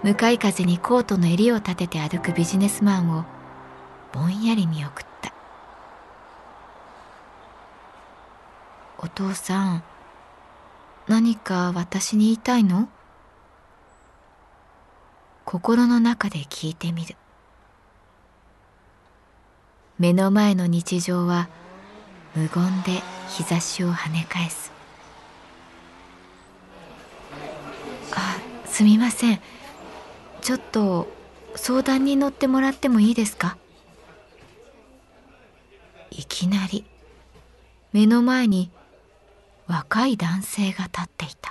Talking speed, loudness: 170 characters per minute, -22 LUFS